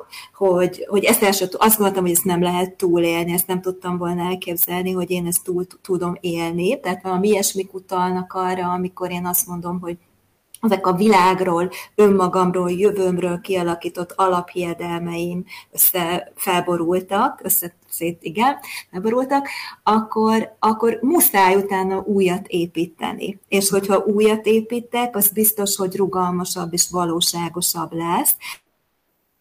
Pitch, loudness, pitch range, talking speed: 185 Hz, -19 LUFS, 175-200 Hz, 130 wpm